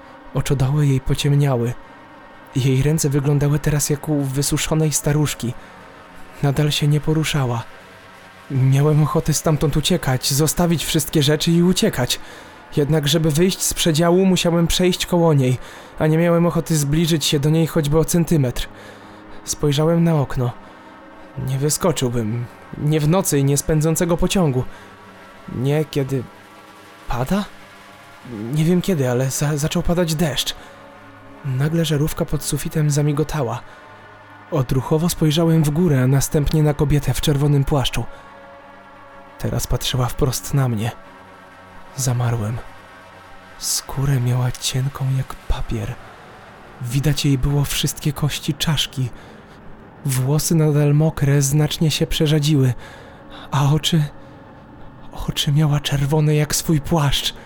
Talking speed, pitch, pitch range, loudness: 120 wpm, 145 Hz, 125-155 Hz, -19 LUFS